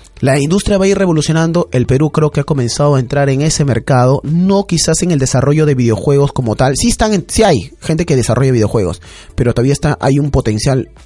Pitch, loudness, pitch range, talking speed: 140 Hz, -12 LUFS, 125-160 Hz, 225 wpm